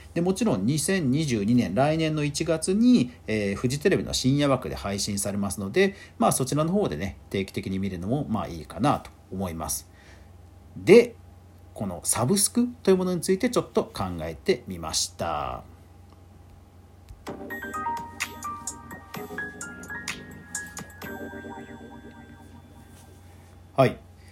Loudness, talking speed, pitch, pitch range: -26 LUFS, 210 characters per minute, 95 Hz, 90-145 Hz